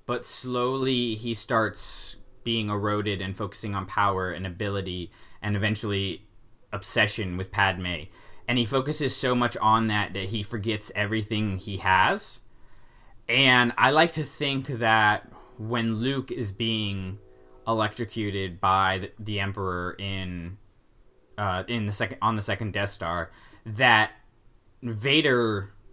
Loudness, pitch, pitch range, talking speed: -26 LUFS, 105 Hz, 95-115 Hz, 130 wpm